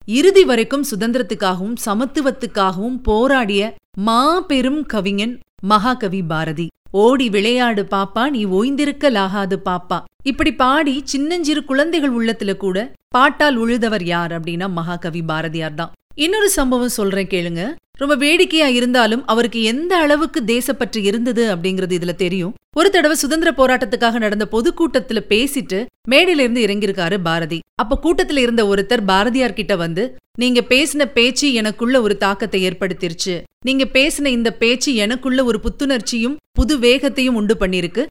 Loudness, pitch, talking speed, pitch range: -16 LUFS, 235 Hz, 125 wpm, 200-275 Hz